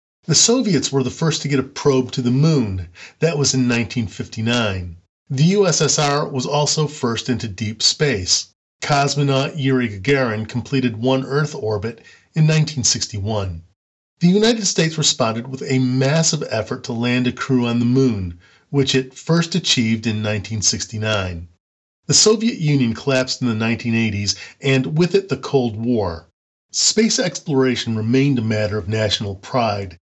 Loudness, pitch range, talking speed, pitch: -18 LUFS, 110-145 Hz, 150 wpm, 125 Hz